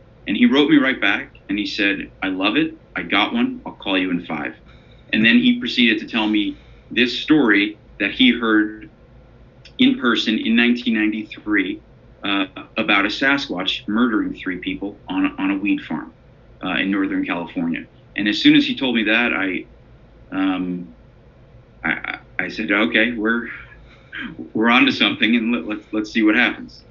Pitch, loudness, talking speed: 125 Hz, -19 LUFS, 175 wpm